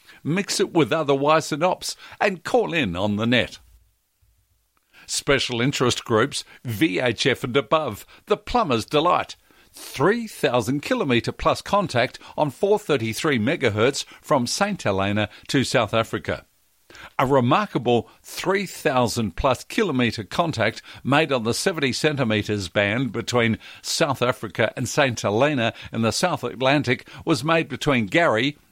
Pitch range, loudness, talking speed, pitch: 110-155 Hz, -22 LUFS, 125 wpm, 125 Hz